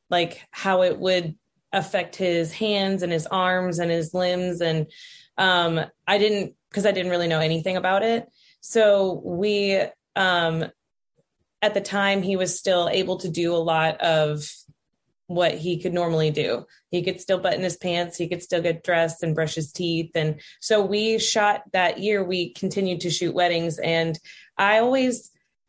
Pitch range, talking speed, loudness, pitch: 165-195 Hz, 175 wpm, -23 LUFS, 180 Hz